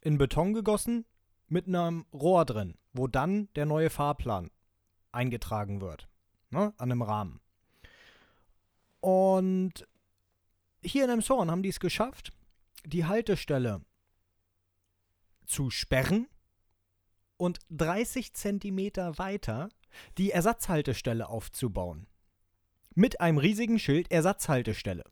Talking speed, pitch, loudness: 100 wpm, 130 Hz, -30 LUFS